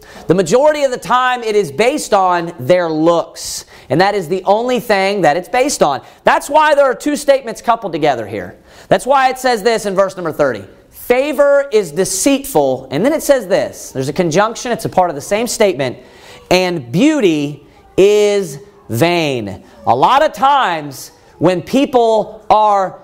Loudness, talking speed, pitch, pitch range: -14 LUFS, 175 wpm, 200 Hz, 170-250 Hz